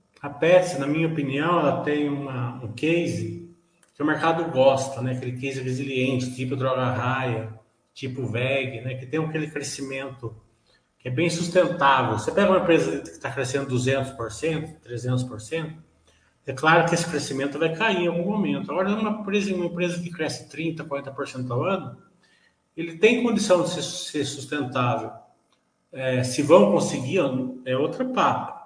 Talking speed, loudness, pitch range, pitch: 160 wpm, -24 LUFS, 130-170 Hz, 140 Hz